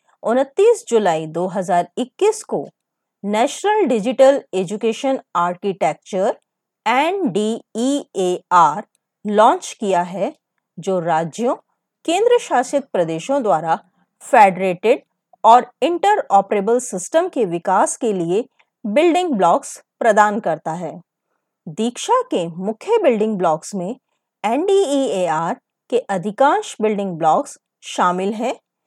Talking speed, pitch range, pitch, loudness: 110 wpm, 190-275 Hz, 225 Hz, -18 LUFS